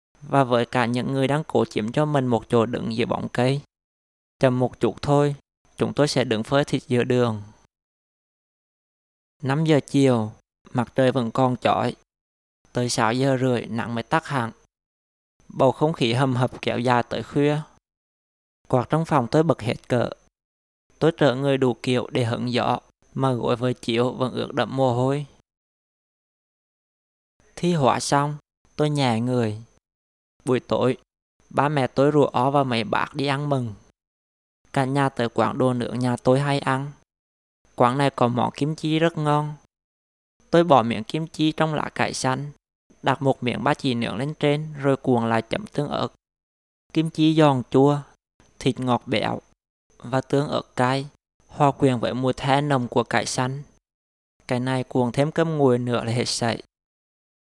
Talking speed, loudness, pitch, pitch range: 175 wpm, -23 LUFS, 130 Hz, 115-140 Hz